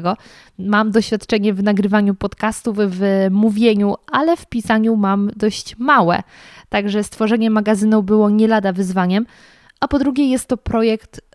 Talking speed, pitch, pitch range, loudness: 135 wpm, 215 Hz, 205-225 Hz, -17 LUFS